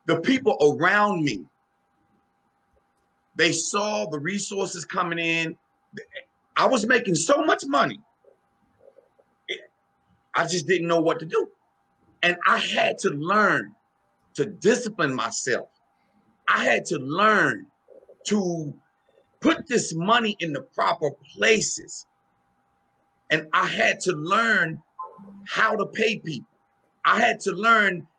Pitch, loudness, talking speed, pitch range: 190 Hz, -23 LUFS, 120 wpm, 165-225 Hz